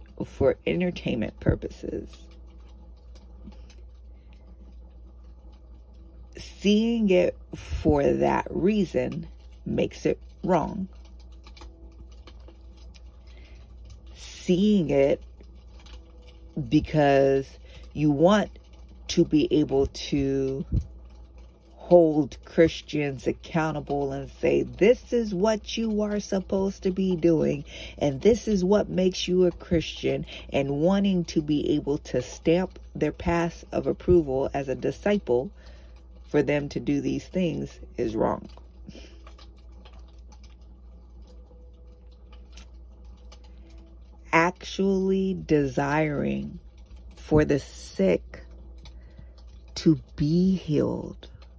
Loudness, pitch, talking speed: -25 LUFS, 70 Hz, 85 wpm